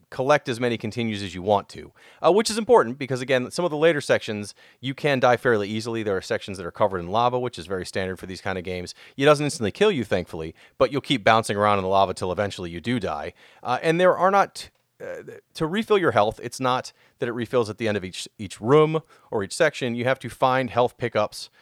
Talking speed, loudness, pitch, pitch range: 255 wpm, -23 LUFS, 120 Hz, 100-145 Hz